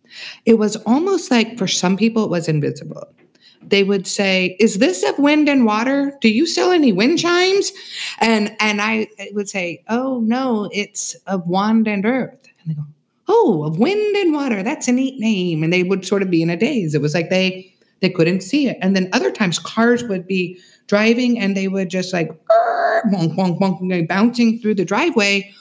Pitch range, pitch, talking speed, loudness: 185-250 Hz, 215 Hz, 200 wpm, -17 LUFS